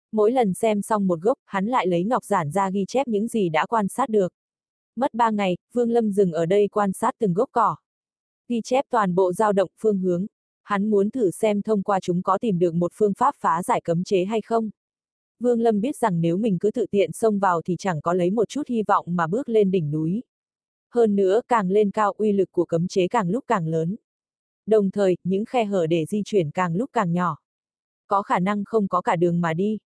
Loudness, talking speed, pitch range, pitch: -22 LUFS, 240 wpm, 180-225 Hz, 200 Hz